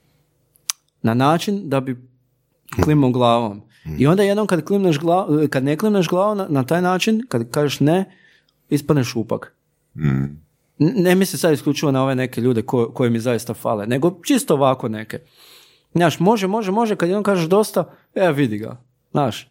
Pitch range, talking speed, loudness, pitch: 125-180 Hz, 165 wpm, -19 LUFS, 150 Hz